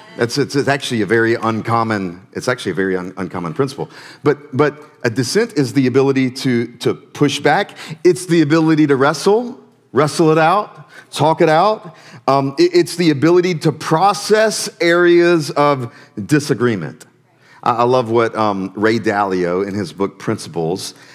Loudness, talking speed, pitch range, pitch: -16 LUFS, 155 wpm, 115-165 Hz, 140 Hz